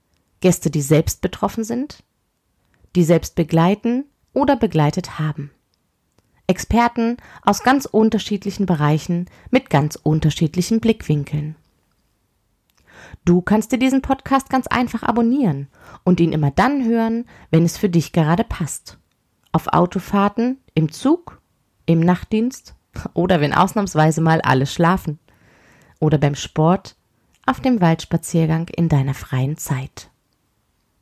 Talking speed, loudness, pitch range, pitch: 120 wpm, -19 LUFS, 150-225 Hz, 170 Hz